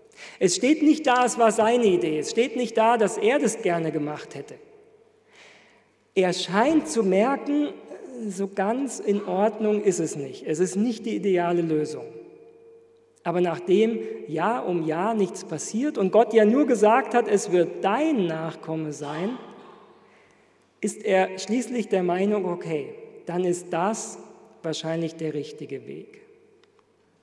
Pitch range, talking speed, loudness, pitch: 175-270 Hz, 145 wpm, -24 LUFS, 210 Hz